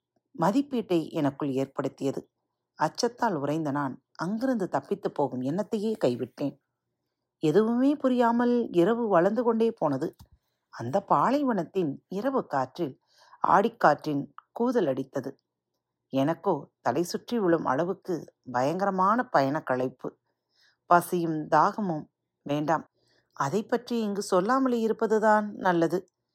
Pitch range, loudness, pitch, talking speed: 145-225 Hz, -27 LUFS, 180 Hz, 90 wpm